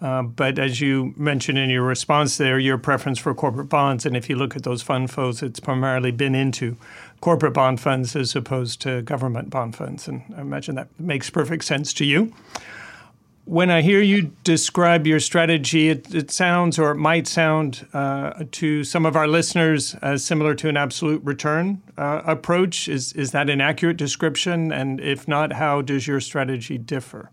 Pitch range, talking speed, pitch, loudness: 135-160 Hz, 190 wpm, 145 Hz, -21 LUFS